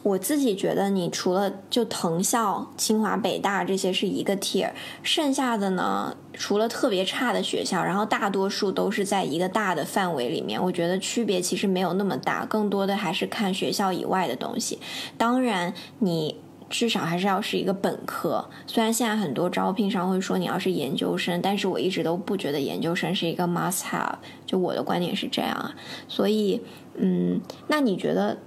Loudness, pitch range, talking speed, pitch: -25 LUFS, 180-215 Hz, 310 characters per minute, 195 Hz